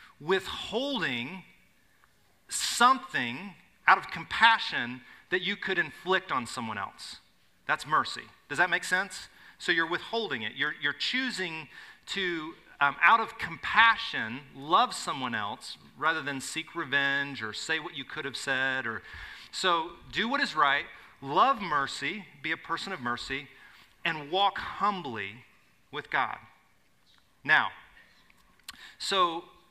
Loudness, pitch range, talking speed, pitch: -28 LUFS, 140-220 Hz, 130 wpm, 175 Hz